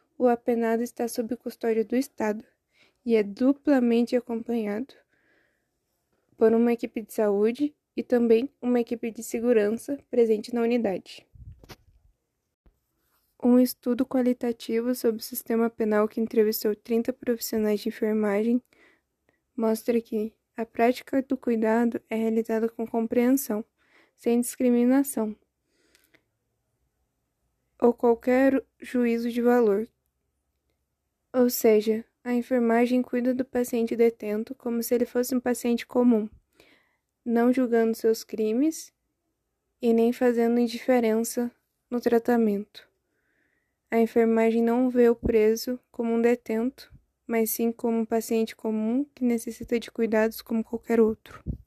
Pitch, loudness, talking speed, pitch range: 235 Hz, -25 LUFS, 120 wpm, 225-245 Hz